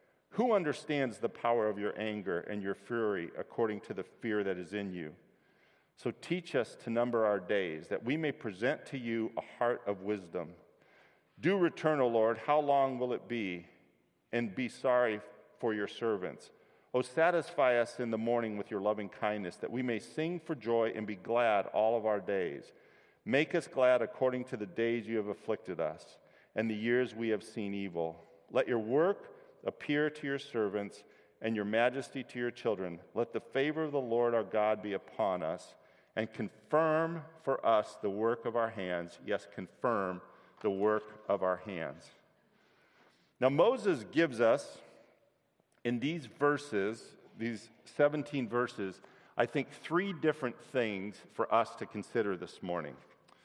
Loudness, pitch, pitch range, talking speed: -34 LUFS, 115 Hz, 105-135 Hz, 170 wpm